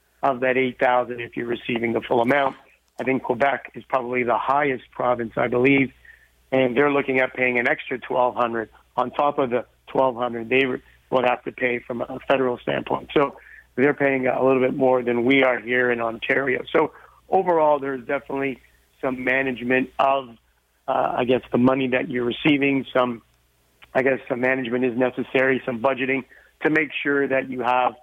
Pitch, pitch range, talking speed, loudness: 130 Hz, 125-135 Hz, 185 wpm, -22 LUFS